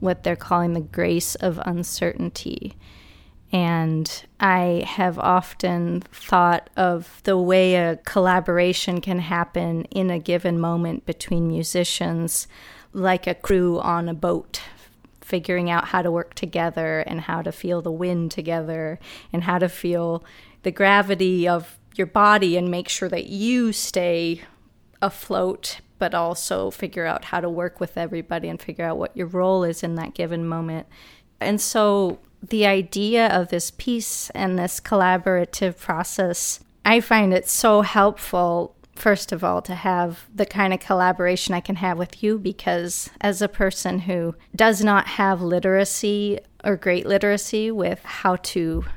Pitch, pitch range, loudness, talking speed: 180 Hz, 170-195 Hz, -22 LUFS, 155 wpm